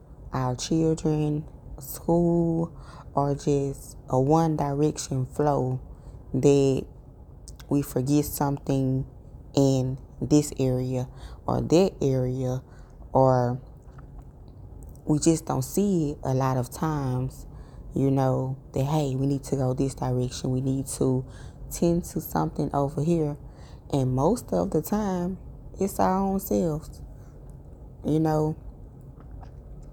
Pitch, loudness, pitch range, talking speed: 140 Hz, -26 LUFS, 130-155 Hz, 115 wpm